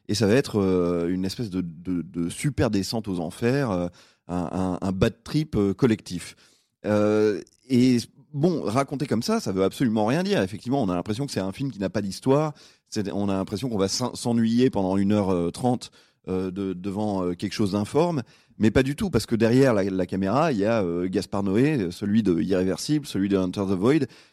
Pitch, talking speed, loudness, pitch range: 105 Hz, 195 wpm, -24 LUFS, 95-125 Hz